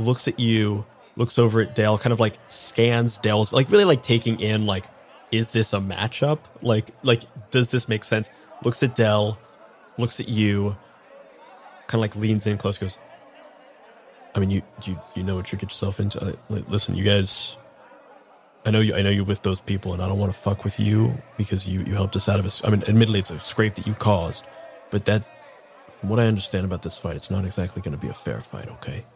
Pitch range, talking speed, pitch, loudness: 100-115 Hz, 230 wpm, 105 Hz, -23 LUFS